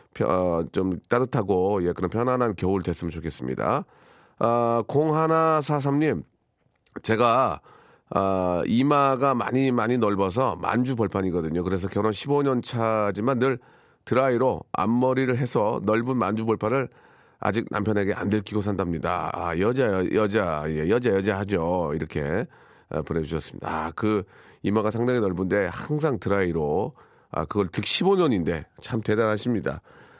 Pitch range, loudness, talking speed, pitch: 95-125 Hz, -25 LUFS, 295 characters per minute, 105 Hz